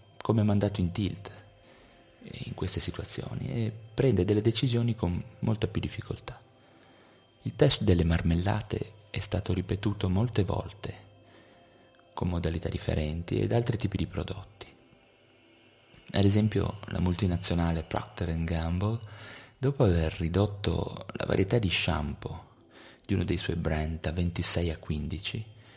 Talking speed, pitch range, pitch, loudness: 125 wpm, 85-110 Hz, 100 Hz, -29 LUFS